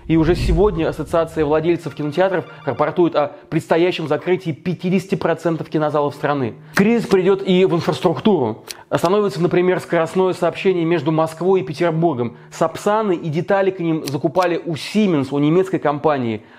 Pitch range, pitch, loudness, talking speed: 155-180 Hz, 170 Hz, -18 LUFS, 135 wpm